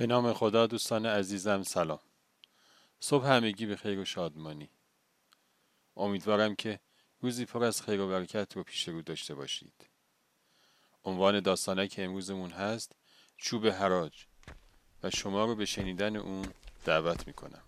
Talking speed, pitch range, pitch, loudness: 135 wpm, 95-110 Hz, 100 Hz, -32 LUFS